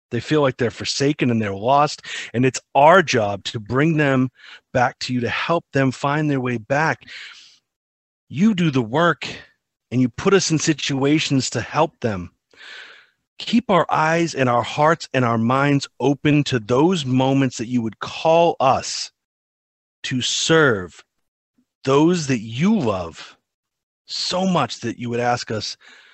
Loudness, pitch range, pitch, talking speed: -19 LUFS, 120-155 Hz, 135 Hz, 160 wpm